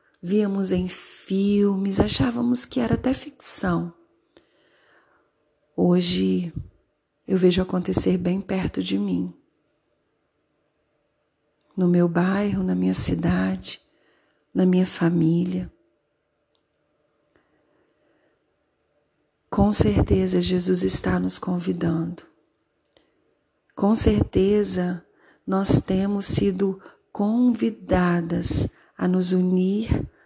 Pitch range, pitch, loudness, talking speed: 120-190 Hz, 175 Hz, -22 LUFS, 80 wpm